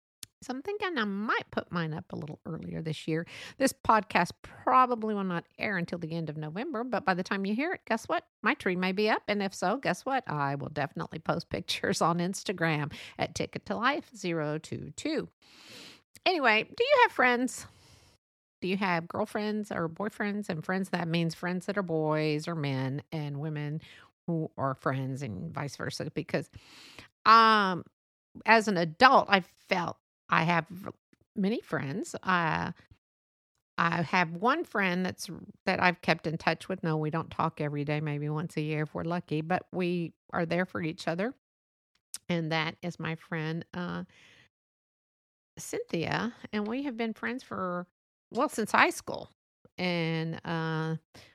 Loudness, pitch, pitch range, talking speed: -30 LUFS, 175 Hz, 160-210 Hz, 170 wpm